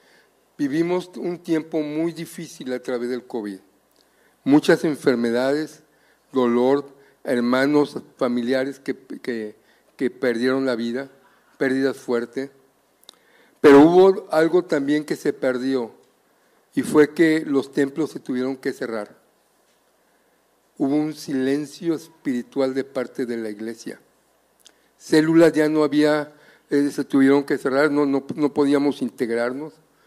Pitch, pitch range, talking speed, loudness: 140 Hz, 130-150 Hz, 120 wpm, -21 LUFS